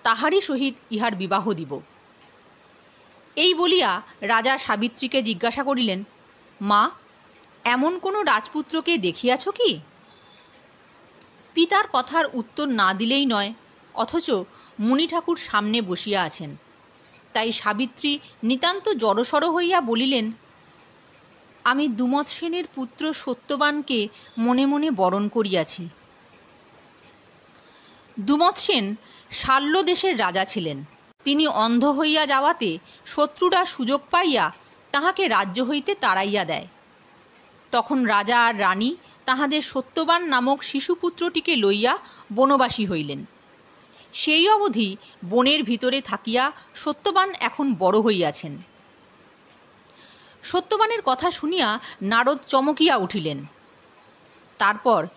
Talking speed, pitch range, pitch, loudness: 95 wpm, 215-315 Hz, 260 Hz, -22 LUFS